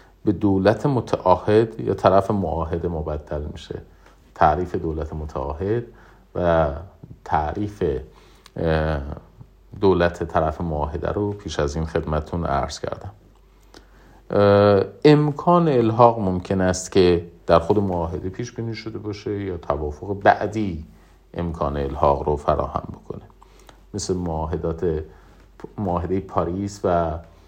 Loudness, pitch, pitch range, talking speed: -22 LUFS, 90 Hz, 80-100 Hz, 105 wpm